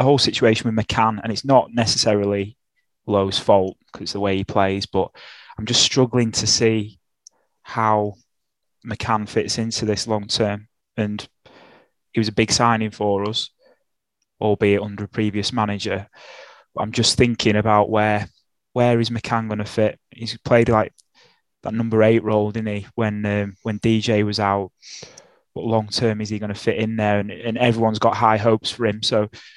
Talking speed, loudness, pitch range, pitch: 175 wpm, -20 LUFS, 105-115 Hz, 110 Hz